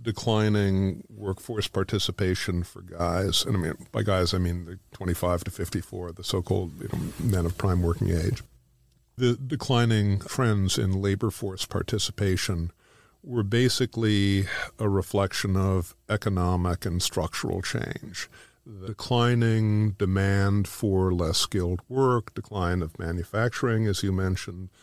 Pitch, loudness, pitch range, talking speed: 100 Hz, -27 LUFS, 90-110 Hz, 130 wpm